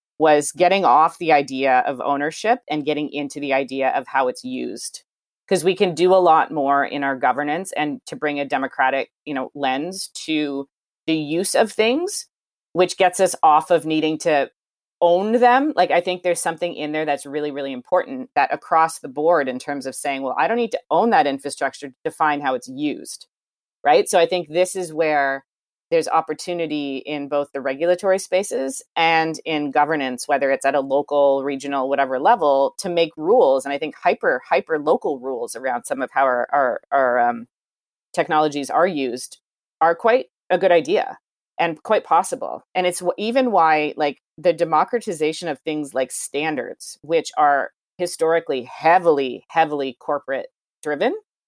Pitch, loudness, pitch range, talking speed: 155 Hz, -20 LUFS, 140-180 Hz, 175 wpm